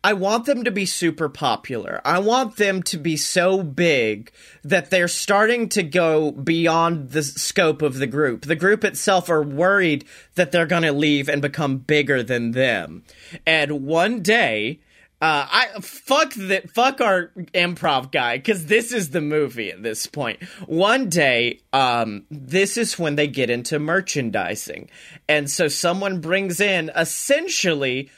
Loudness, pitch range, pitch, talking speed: -20 LUFS, 150-195 Hz, 170 Hz, 160 wpm